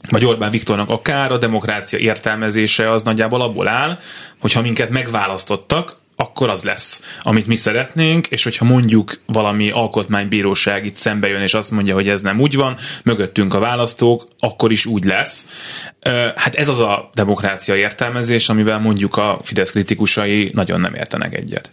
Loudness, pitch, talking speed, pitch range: -16 LUFS, 110 Hz, 160 wpm, 105-120 Hz